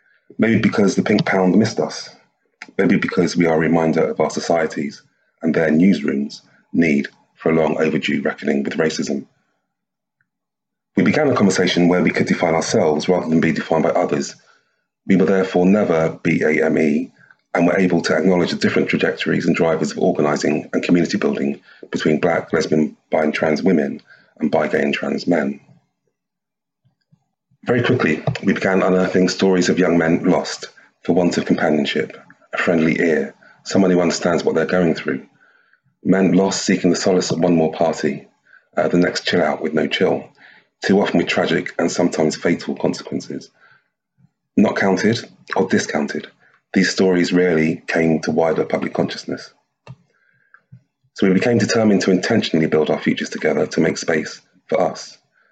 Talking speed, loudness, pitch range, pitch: 165 wpm, -18 LUFS, 80-95 Hz, 85 Hz